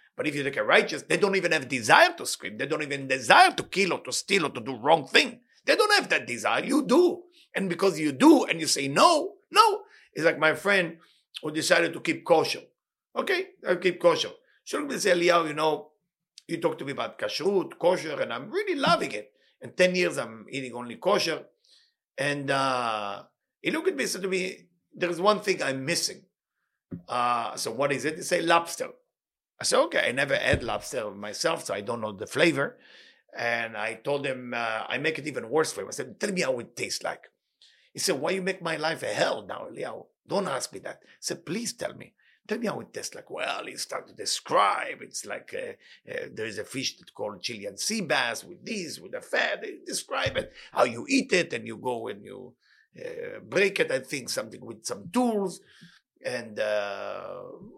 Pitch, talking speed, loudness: 195 Hz, 215 wpm, -26 LUFS